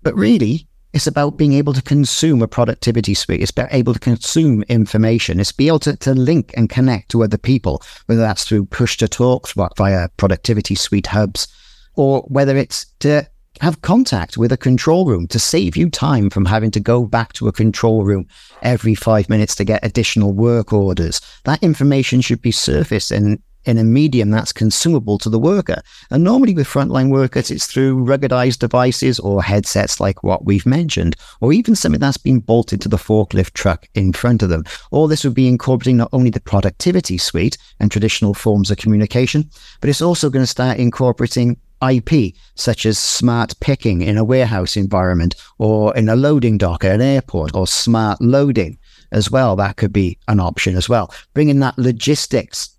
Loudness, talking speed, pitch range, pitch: -15 LUFS, 190 wpm, 105-130 Hz, 115 Hz